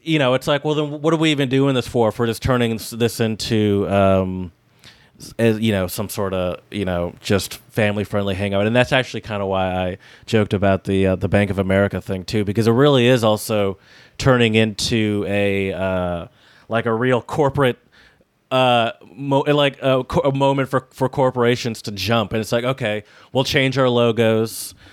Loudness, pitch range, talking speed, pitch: -19 LUFS, 100-130 Hz, 195 wpm, 110 Hz